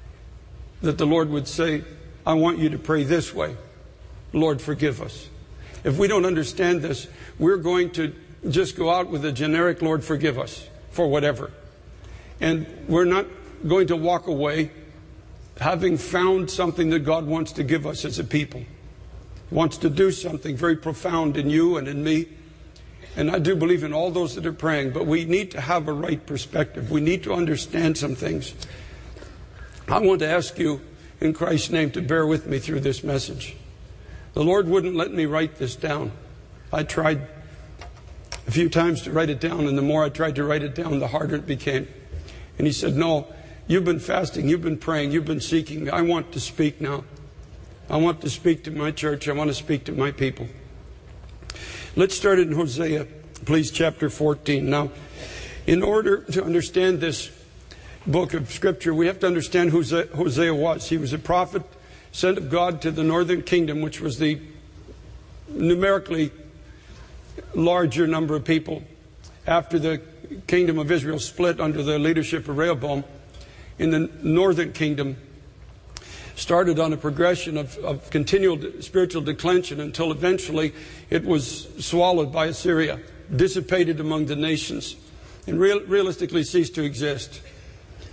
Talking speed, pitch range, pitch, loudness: 170 wpm, 145-170 Hz, 155 Hz, -23 LUFS